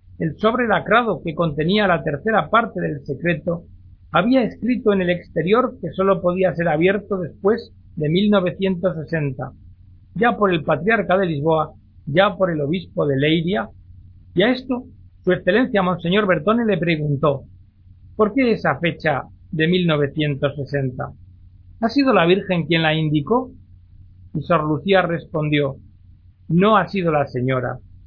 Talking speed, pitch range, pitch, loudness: 140 wpm, 135-195 Hz, 165 Hz, -19 LUFS